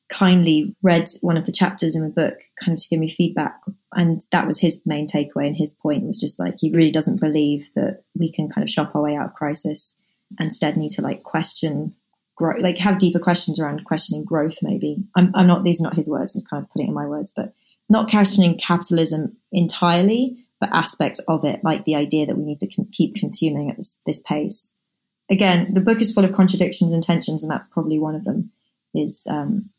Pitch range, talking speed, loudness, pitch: 155-195 Hz, 225 wpm, -20 LUFS, 175 Hz